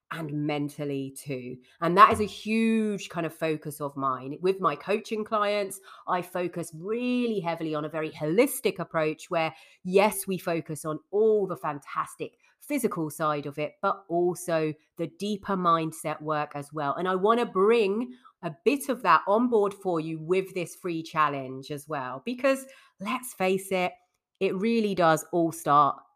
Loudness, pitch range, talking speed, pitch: -27 LUFS, 155-205 Hz, 165 wpm, 175 Hz